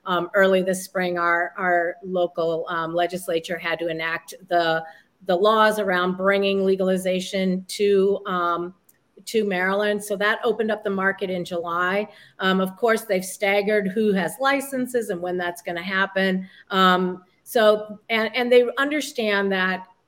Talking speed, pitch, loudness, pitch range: 150 wpm, 190 Hz, -22 LUFS, 180-210 Hz